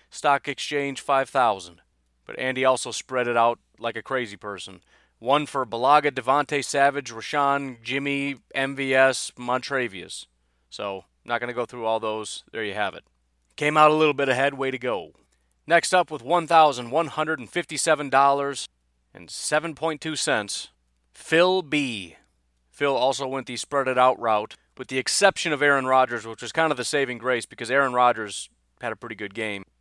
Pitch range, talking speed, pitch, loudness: 110-145 Hz, 180 wpm, 130 Hz, -23 LUFS